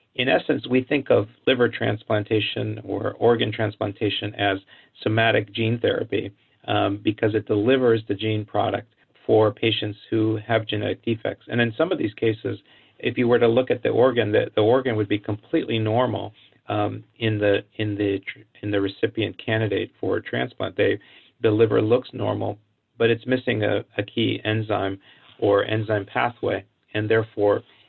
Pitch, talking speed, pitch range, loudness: 110 Hz, 165 wpm, 105-115 Hz, -23 LUFS